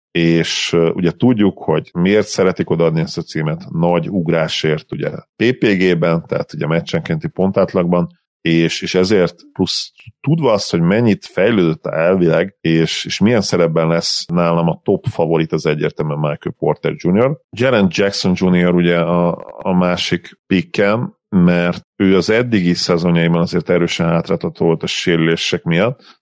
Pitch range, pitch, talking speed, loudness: 85-90 Hz, 85 Hz, 145 wpm, -16 LUFS